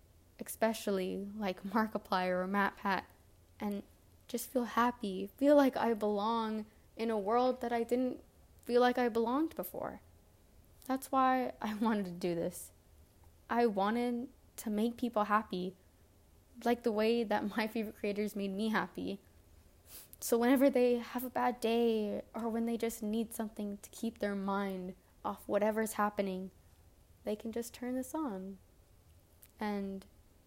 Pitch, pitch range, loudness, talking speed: 210 Hz, 185-235 Hz, -35 LUFS, 145 wpm